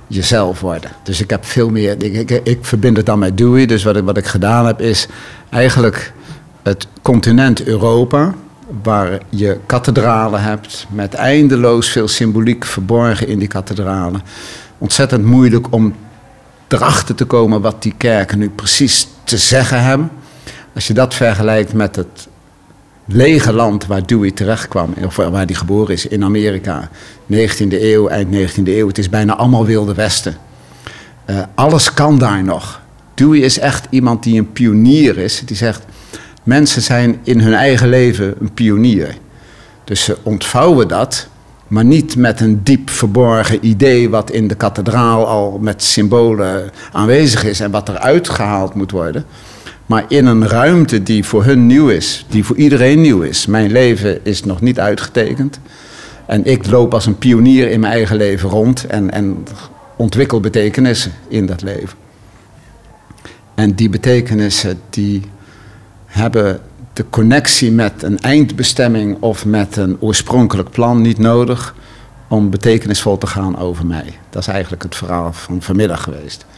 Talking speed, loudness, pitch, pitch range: 155 wpm, -12 LUFS, 110 Hz, 100-120 Hz